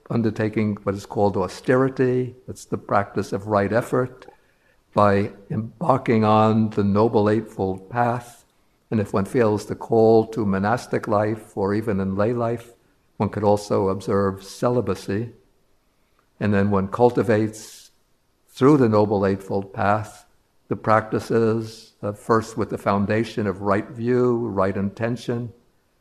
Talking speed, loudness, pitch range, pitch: 135 wpm, -22 LUFS, 100-115 Hz, 110 Hz